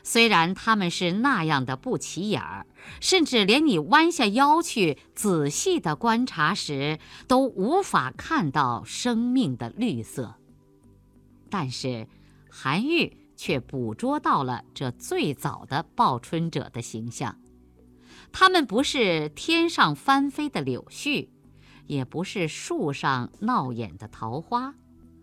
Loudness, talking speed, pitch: -24 LUFS, 180 characters per minute, 170 Hz